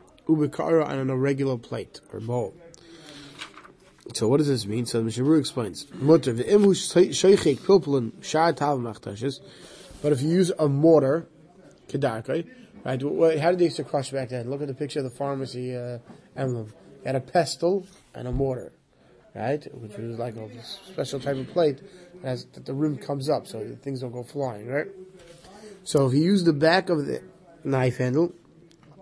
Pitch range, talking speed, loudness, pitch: 130-165 Hz, 165 wpm, -25 LUFS, 145 Hz